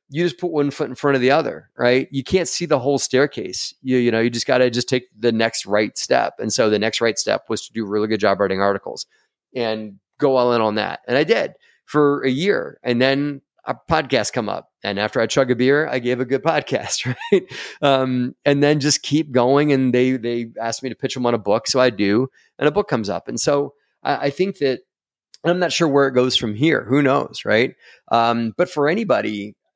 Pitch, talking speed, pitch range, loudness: 130 Hz, 245 wpm, 120-145 Hz, -19 LUFS